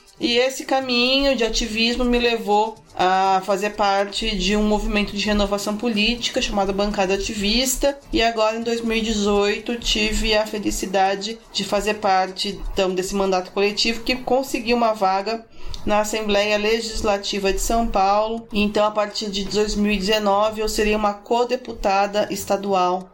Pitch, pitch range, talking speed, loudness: 210 Hz, 200-230 Hz, 135 wpm, -20 LUFS